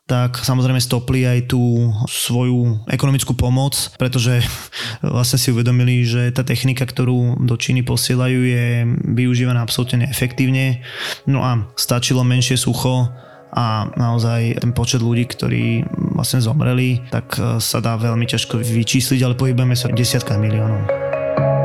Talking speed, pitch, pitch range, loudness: 135 wpm, 125 Hz, 120-130 Hz, -17 LUFS